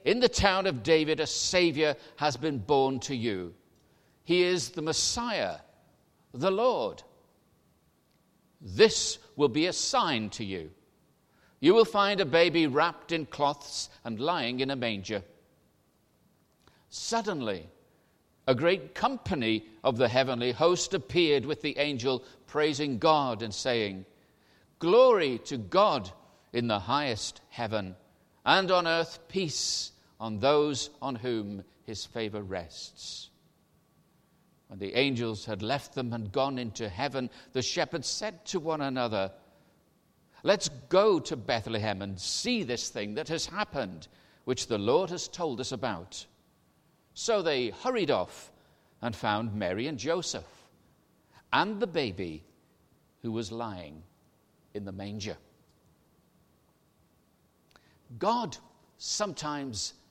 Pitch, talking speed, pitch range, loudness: 135 Hz, 125 wpm, 110-165 Hz, -29 LUFS